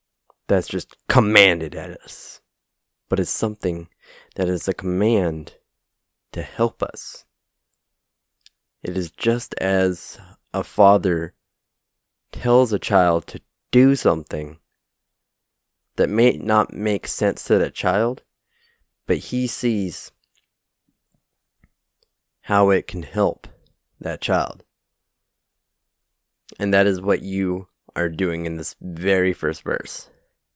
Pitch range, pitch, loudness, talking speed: 90-110 Hz, 95 Hz, -21 LUFS, 110 wpm